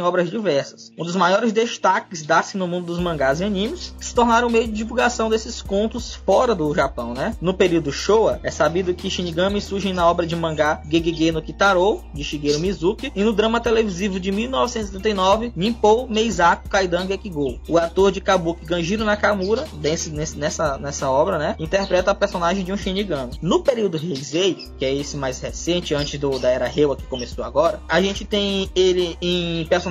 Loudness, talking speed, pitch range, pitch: -20 LUFS, 185 wpm, 165-210 Hz, 185 Hz